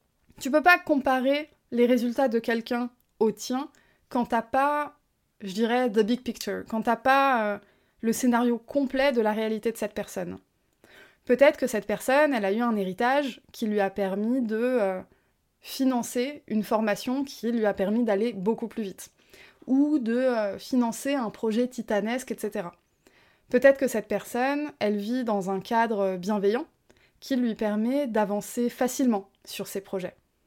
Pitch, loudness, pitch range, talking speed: 235 Hz, -26 LUFS, 210-260 Hz, 165 wpm